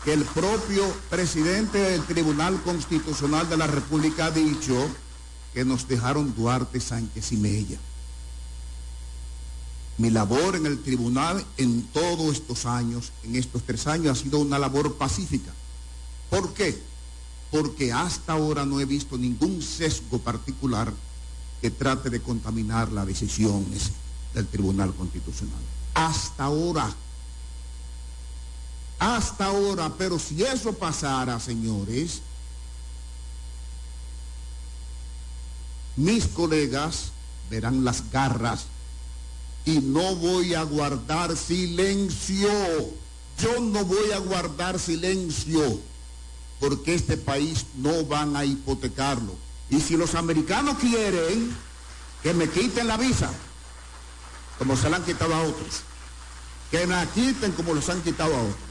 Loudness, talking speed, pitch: -26 LUFS, 120 wpm, 125 Hz